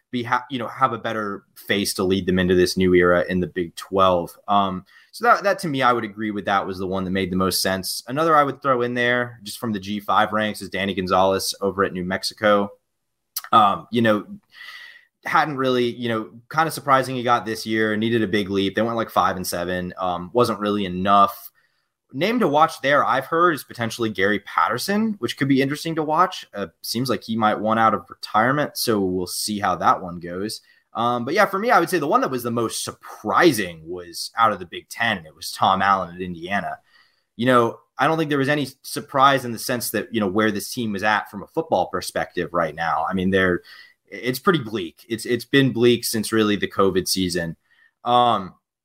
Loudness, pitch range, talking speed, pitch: -21 LUFS, 95-120 Hz, 225 wpm, 110 Hz